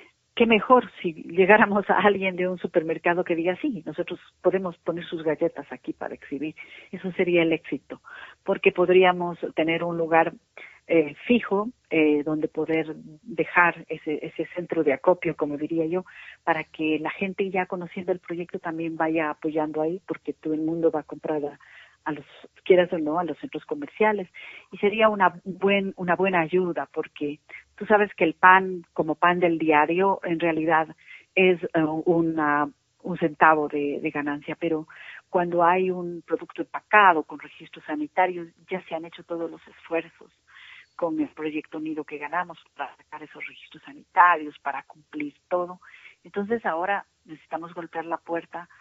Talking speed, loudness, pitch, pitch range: 165 wpm, -24 LUFS, 170 Hz, 155-185 Hz